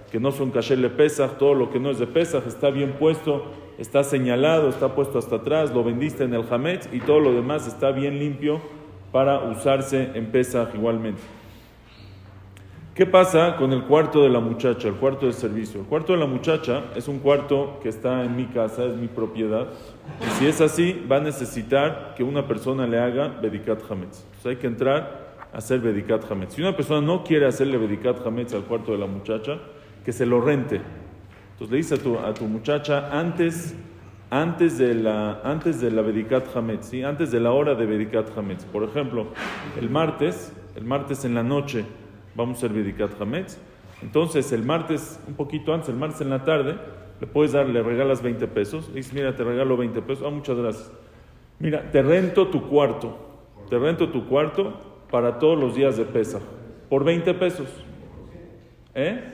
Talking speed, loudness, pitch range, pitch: 195 wpm, -23 LUFS, 115-145 Hz, 130 Hz